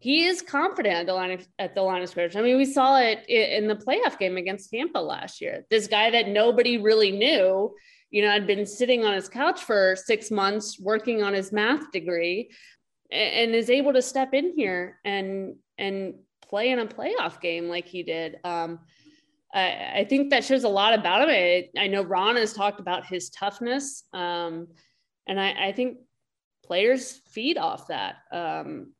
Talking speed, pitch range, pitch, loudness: 190 wpm, 185-255 Hz, 210 Hz, -24 LUFS